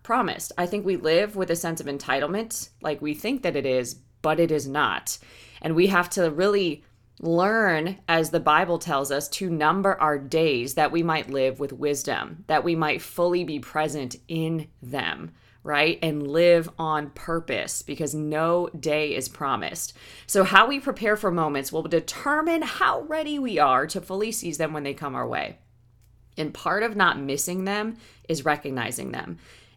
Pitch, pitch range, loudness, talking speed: 160 Hz, 140-180 Hz, -24 LUFS, 180 wpm